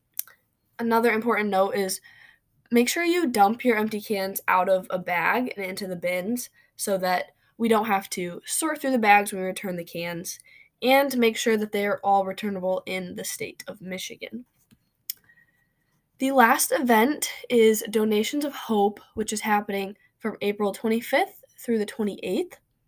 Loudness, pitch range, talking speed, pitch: -24 LUFS, 195-245 Hz, 165 wpm, 215 Hz